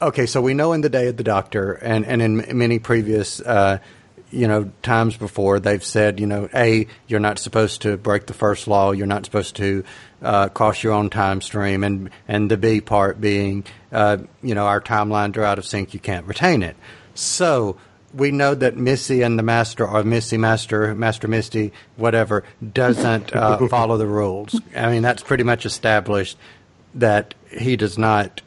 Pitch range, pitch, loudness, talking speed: 100-115 Hz, 110 Hz, -19 LUFS, 190 wpm